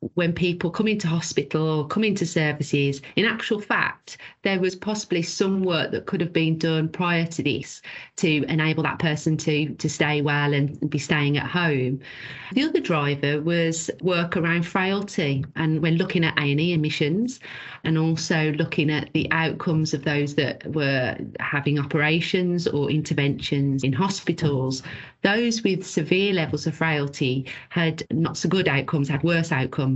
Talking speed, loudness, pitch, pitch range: 160 wpm, -23 LUFS, 160 Hz, 145-175 Hz